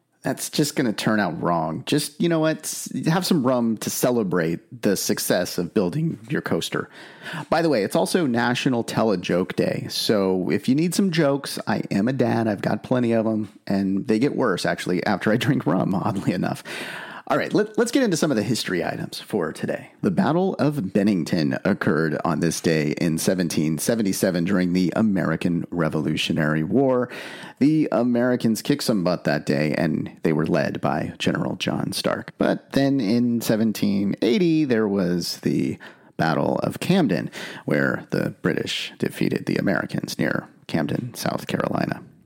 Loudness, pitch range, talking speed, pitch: -23 LUFS, 90-135 Hz, 170 wpm, 110 Hz